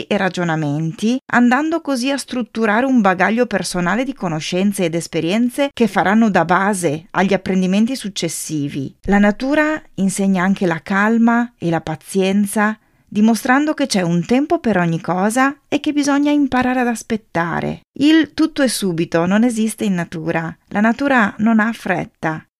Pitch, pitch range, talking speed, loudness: 210 Hz, 175-250 Hz, 150 wpm, -17 LUFS